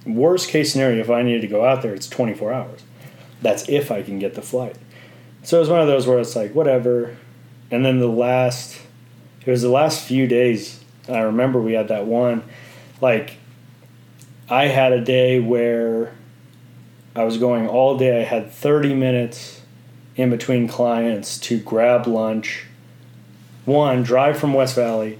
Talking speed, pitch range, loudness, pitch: 170 wpm, 120-130 Hz, -19 LUFS, 125 Hz